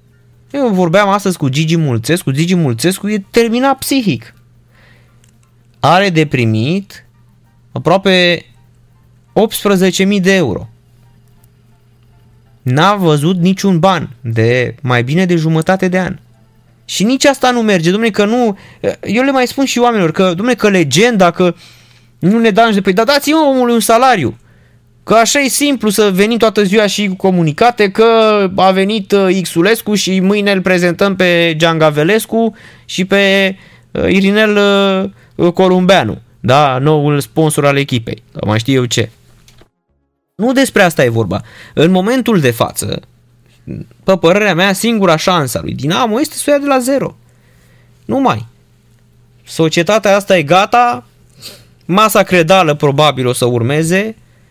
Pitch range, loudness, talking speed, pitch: 125-205 Hz, -11 LUFS, 140 wpm, 180 Hz